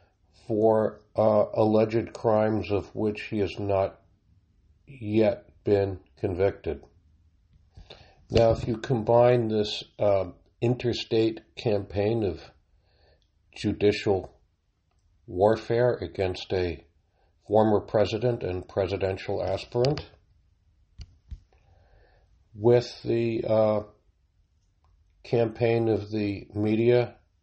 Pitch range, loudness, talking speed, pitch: 90-110 Hz, -26 LUFS, 80 wpm, 100 Hz